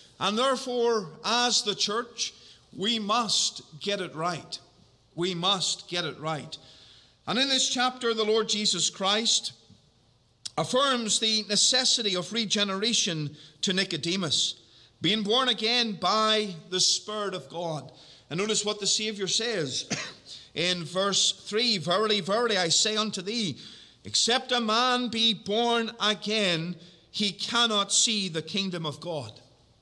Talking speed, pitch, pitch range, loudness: 135 wpm, 200 Hz, 165-220 Hz, -26 LUFS